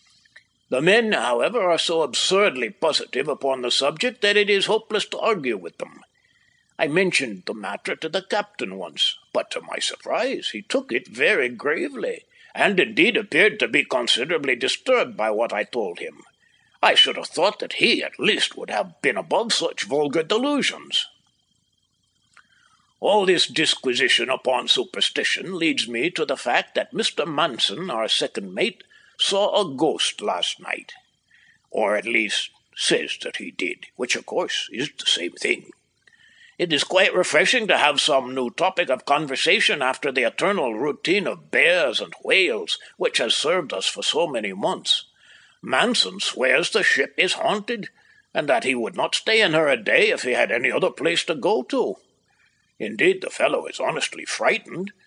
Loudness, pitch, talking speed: -21 LUFS, 365 Hz, 170 wpm